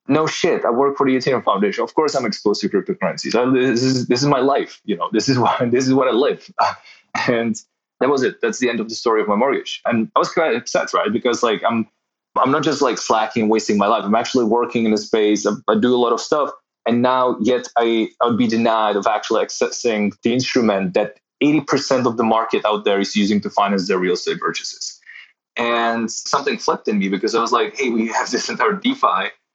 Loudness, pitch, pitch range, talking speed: -18 LUFS, 115 Hz, 110-125 Hz, 235 wpm